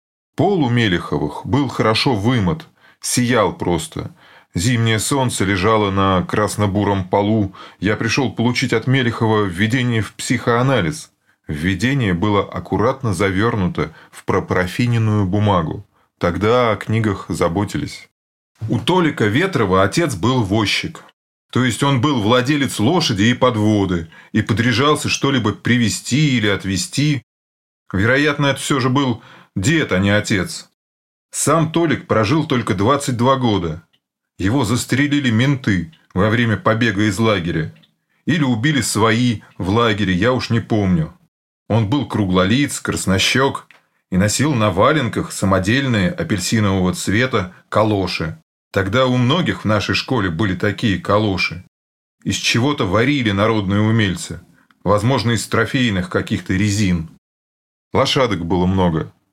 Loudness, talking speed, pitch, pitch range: -17 LUFS, 120 wpm, 110 Hz, 95-130 Hz